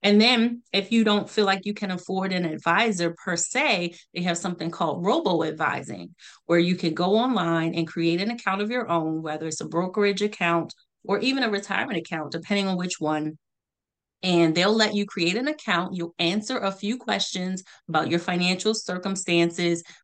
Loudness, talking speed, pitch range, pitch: -24 LUFS, 185 wpm, 170-205 Hz, 180 Hz